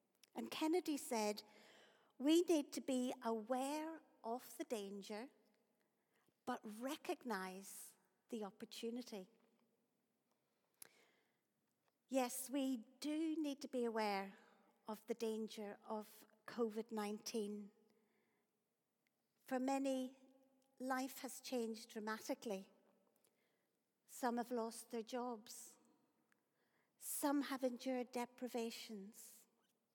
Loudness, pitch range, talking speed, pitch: -45 LUFS, 215-260 Hz, 85 wpm, 230 Hz